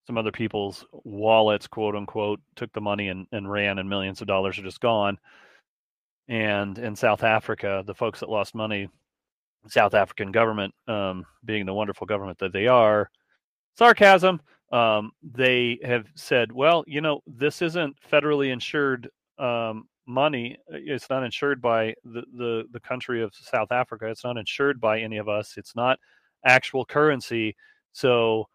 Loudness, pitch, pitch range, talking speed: -24 LUFS, 115 Hz, 105-130 Hz, 160 wpm